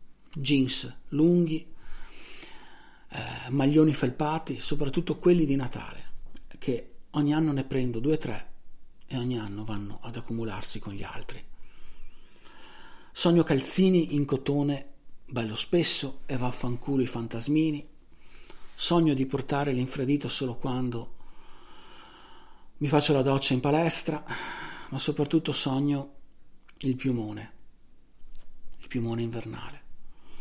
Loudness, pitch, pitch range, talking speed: -28 LUFS, 140 Hz, 125-155 Hz, 110 wpm